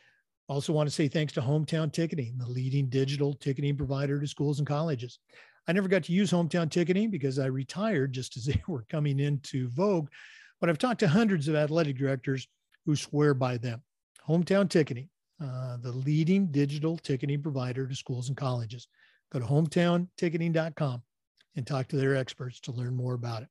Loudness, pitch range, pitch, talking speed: -30 LUFS, 135-165 Hz, 145 Hz, 180 wpm